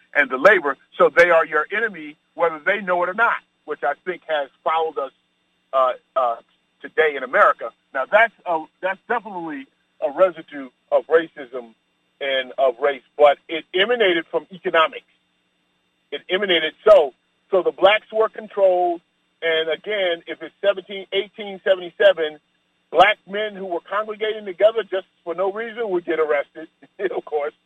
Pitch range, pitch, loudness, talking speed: 150-195 Hz, 170 Hz, -20 LUFS, 155 wpm